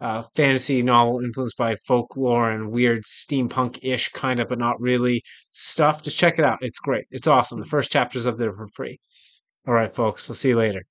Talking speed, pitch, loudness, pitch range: 210 wpm, 125 Hz, -22 LUFS, 115-130 Hz